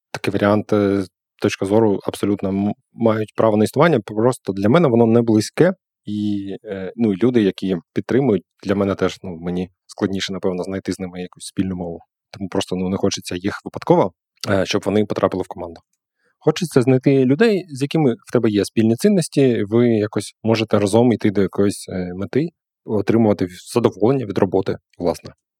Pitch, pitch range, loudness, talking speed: 105 Hz, 95-115 Hz, -19 LUFS, 160 wpm